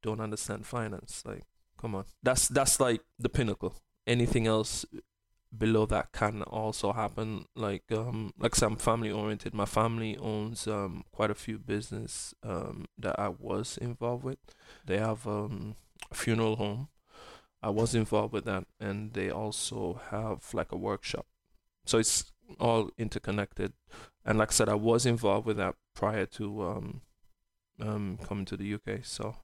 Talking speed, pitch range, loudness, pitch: 160 wpm, 100-110 Hz, -32 LUFS, 110 Hz